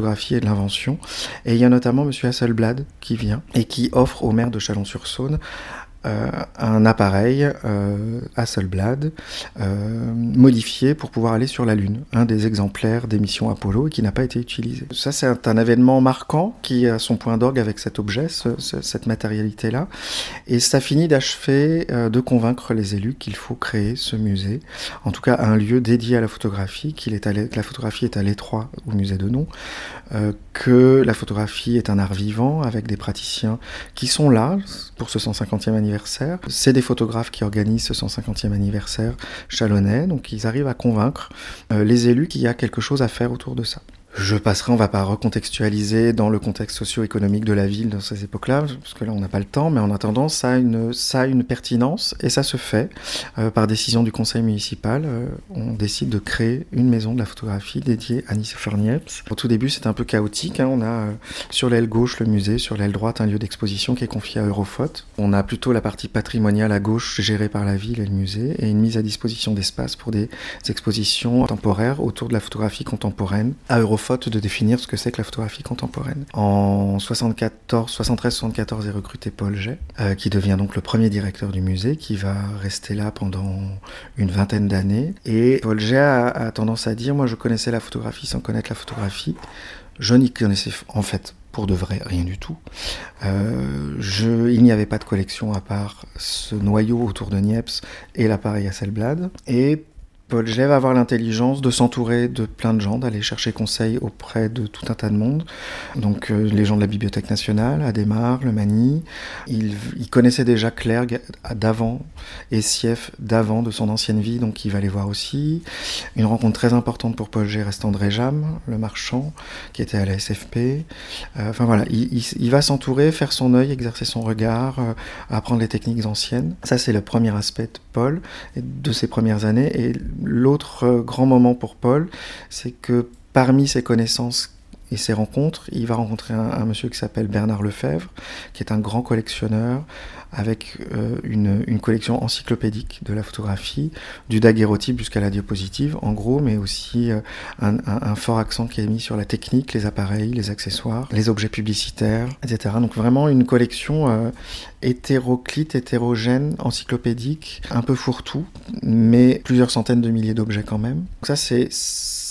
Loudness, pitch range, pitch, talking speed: -21 LUFS, 105-125 Hz, 115 Hz, 195 wpm